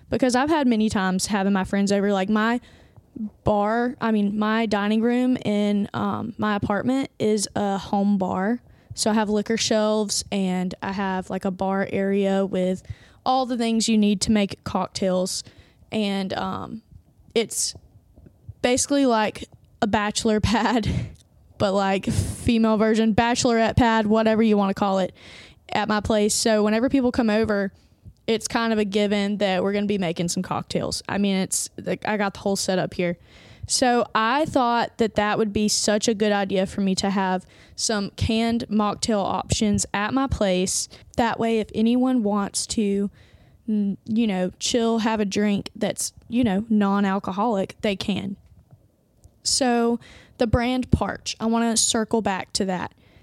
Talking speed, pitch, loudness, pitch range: 165 wpm, 210 Hz, -23 LUFS, 195-225 Hz